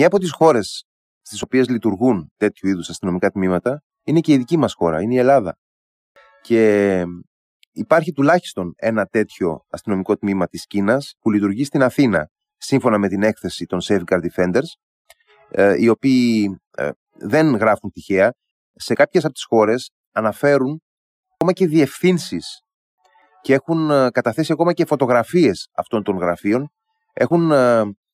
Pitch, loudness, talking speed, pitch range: 120 Hz, -18 LUFS, 135 wpm, 100-150 Hz